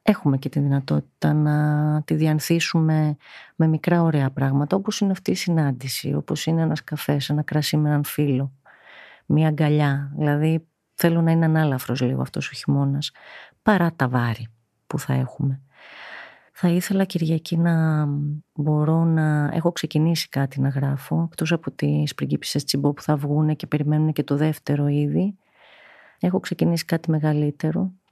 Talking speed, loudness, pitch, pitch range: 150 wpm, -22 LUFS, 150 Hz, 145-165 Hz